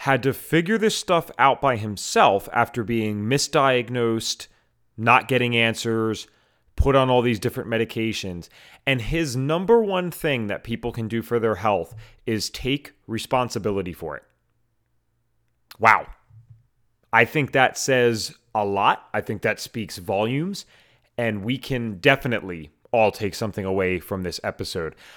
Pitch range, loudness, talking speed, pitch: 110-130 Hz, -22 LUFS, 145 wpm, 115 Hz